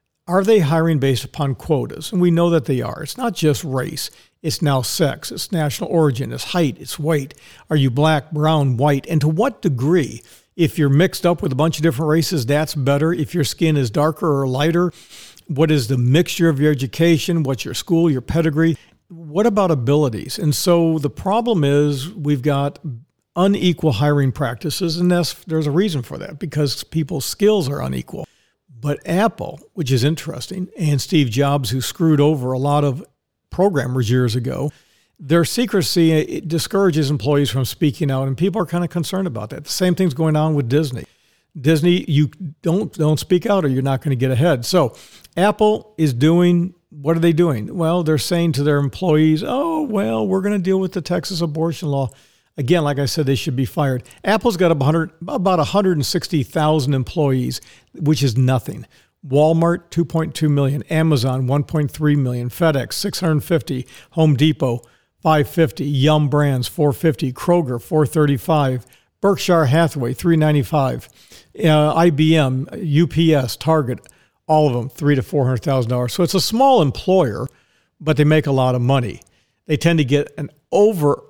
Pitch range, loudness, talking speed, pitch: 140-170 Hz, -18 LUFS, 185 wpm, 155 Hz